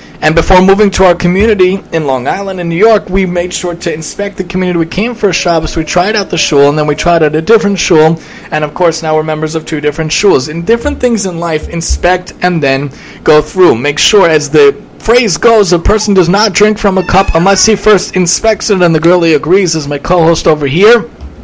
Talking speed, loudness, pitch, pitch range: 240 wpm, -9 LUFS, 180 Hz, 160-200 Hz